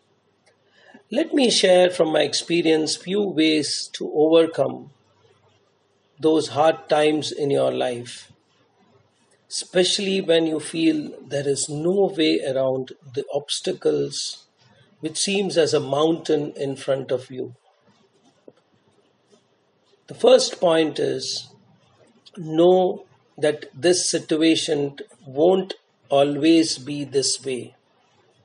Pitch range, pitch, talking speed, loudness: 140-180 Hz, 155 Hz, 105 wpm, -21 LUFS